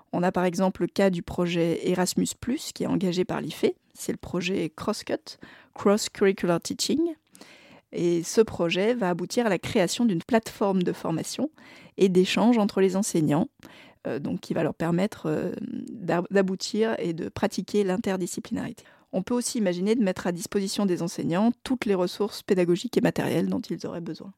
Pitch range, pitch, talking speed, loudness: 180-220 Hz, 195 Hz, 175 wpm, -26 LUFS